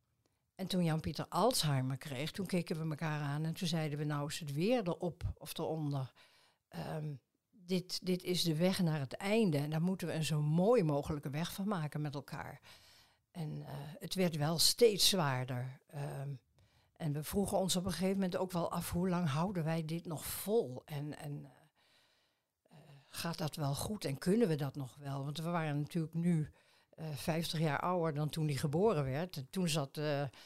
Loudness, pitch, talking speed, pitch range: -36 LUFS, 155 Hz, 200 wpm, 145-175 Hz